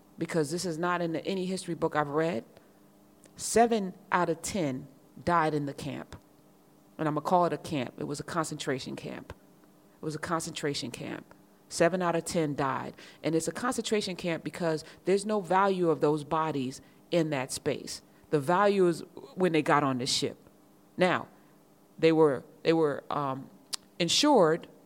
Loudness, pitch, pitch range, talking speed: -29 LUFS, 160 Hz, 145-175 Hz, 170 wpm